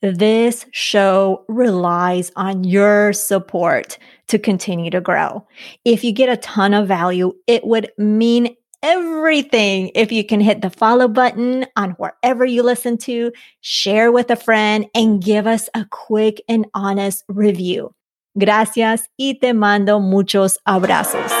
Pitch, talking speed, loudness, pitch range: 215 Hz, 145 wpm, -16 LUFS, 195-235 Hz